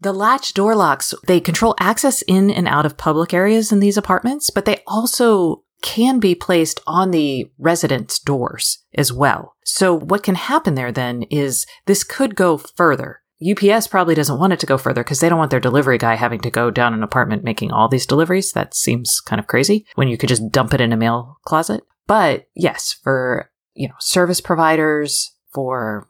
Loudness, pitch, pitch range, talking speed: -17 LUFS, 165 Hz, 130-195 Hz, 200 wpm